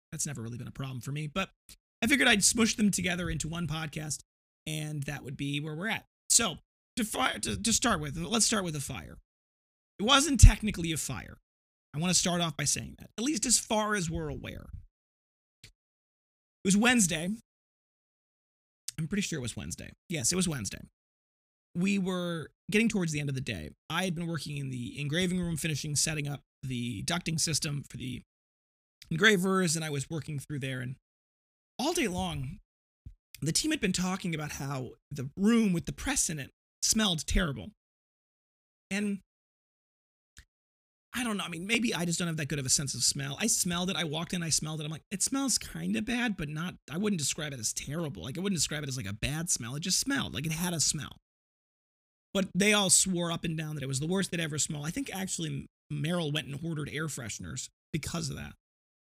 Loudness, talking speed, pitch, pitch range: -30 LUFS, 215 wpm, 160 Hz, 140-190 Hz